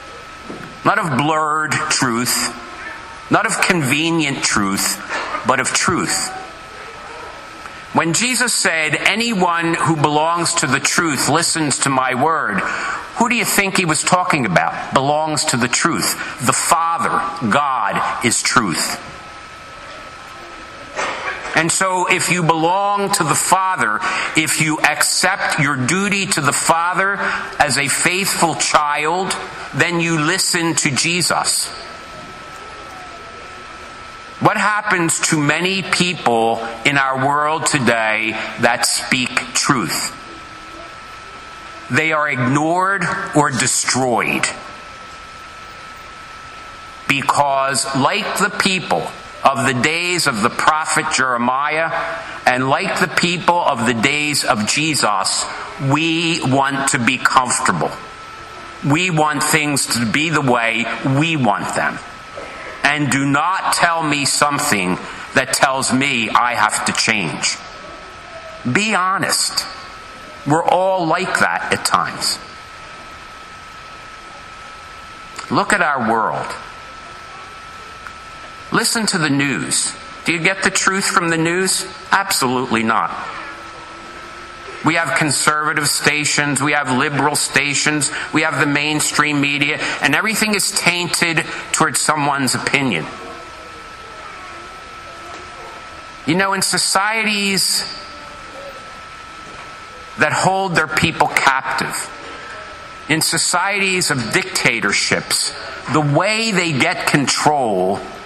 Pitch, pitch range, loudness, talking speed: 155 Hz, 140-180 Hz, -16 LUFS, 110 wpm